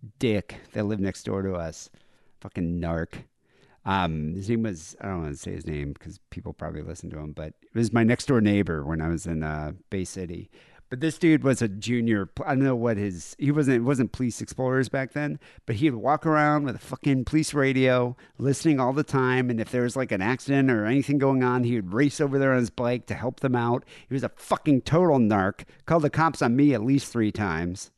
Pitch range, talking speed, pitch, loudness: 95-135 Hz, 225 wpm, 120 Hz, -25 LUFS